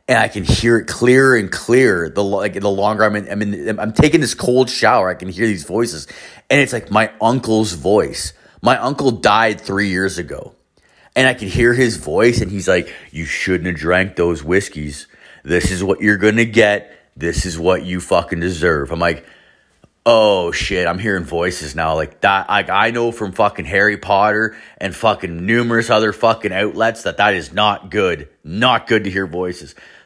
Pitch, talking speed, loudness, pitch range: 100 Hz, 200 wpm, -16 LUFS, 90-115 Hz